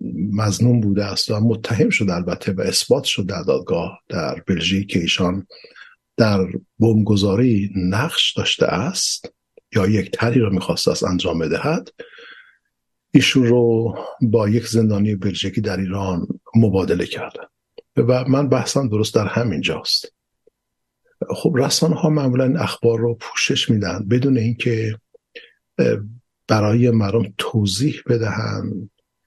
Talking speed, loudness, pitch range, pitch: 125 wpm, -19 LUFS, 100-130 Hz, 115 Hz